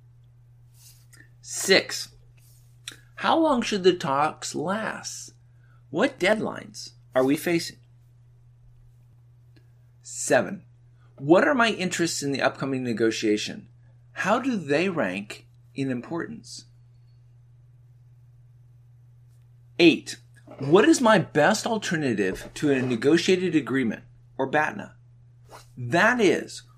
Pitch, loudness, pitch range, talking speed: 120 Hz, -24 LUFS, 120-145 Hz, 90 wpm